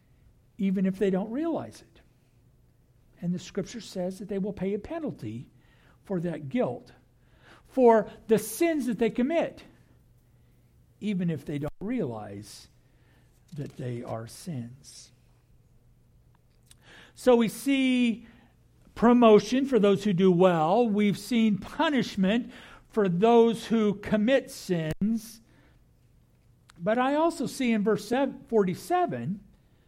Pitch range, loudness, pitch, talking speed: 175-240 Hz, -26 LUFS, 210 Hz, 115 wpm